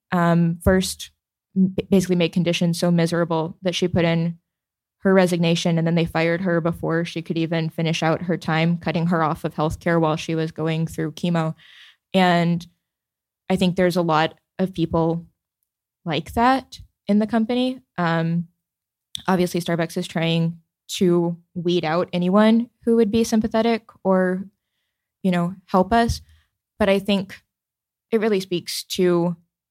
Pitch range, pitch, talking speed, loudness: 165-190 Hz, 175 Hz, 150 wpm, -21 LUFS